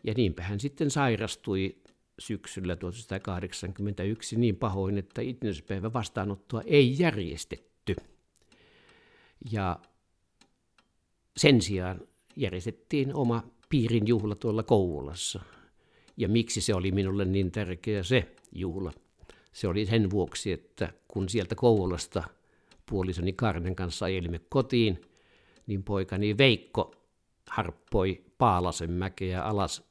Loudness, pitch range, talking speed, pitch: -30 LUFS, 95-115 Hz, 105 wpm, 105 Hz